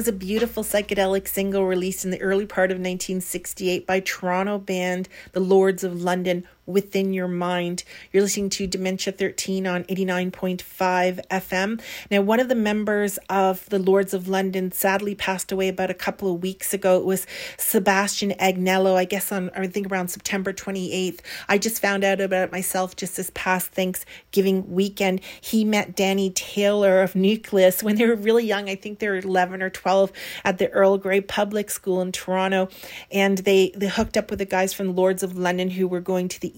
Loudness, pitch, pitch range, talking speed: -23 LUFS, 190 Hz, 185-200 Hz, 195 wpm